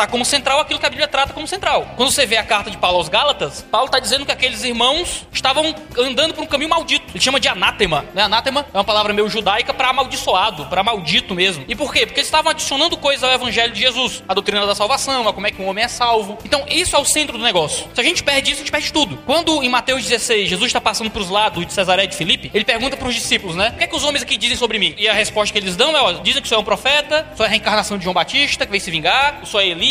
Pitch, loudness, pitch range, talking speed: 245 Hz, -16 LUFS, 210-285 Hz, 285 wpm